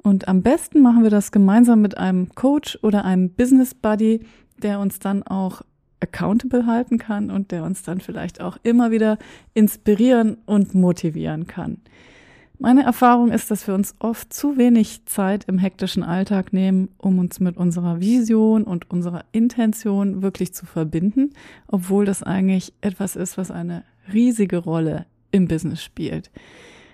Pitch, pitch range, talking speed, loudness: 200 Hz, 185-225 Hz, 155 wpm, -19 LUFS